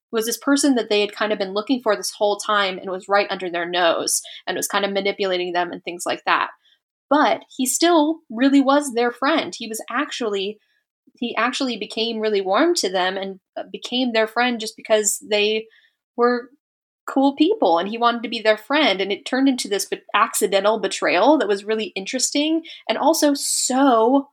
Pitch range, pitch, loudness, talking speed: 205-275 Hz, 230 Hz, -20 LUFS, 190 wpm